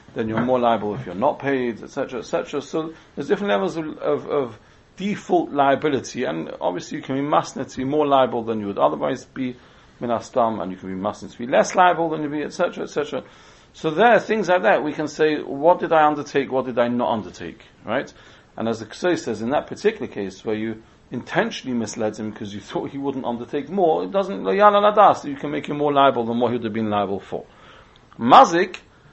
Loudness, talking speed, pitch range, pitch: -21 LUFS, 210 wpm, 115-160 Hz, 140 Hz